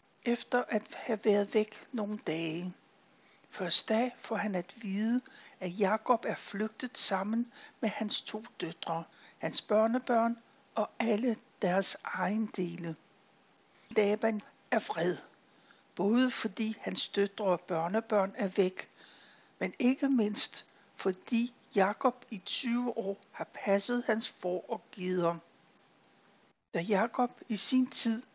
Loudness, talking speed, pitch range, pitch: -31 LUFS, 125 wpm, 195-240 Hz, 215 Hz